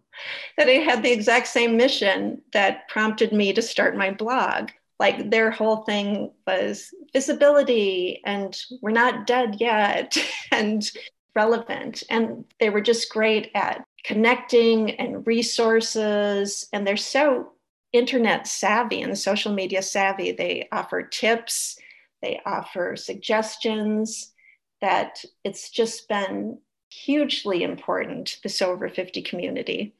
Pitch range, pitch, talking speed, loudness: 210-245 Hz, 225 Hz, 120 wpm, -23 LUFS